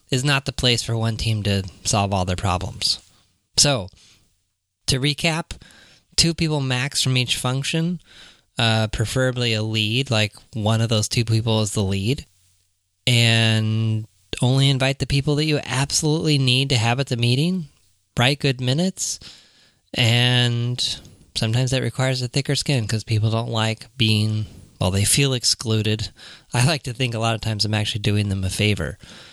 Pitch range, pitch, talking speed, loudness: 105-130 Hz, 115 Hz, 165 wpm, -21 LUFS